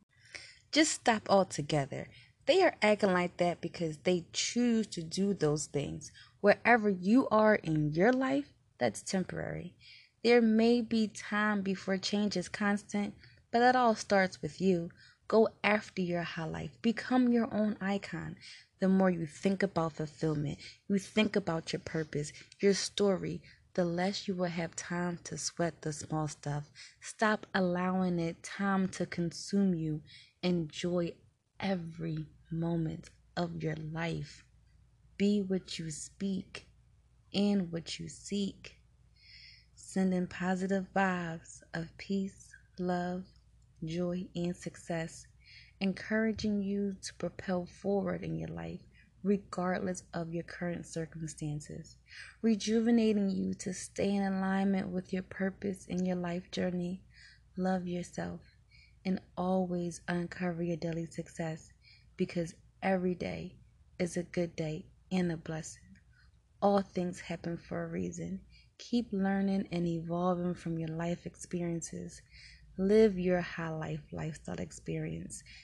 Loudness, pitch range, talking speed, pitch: -33 LUFS, 165-195 Hz, 130 wpm, 180 Hz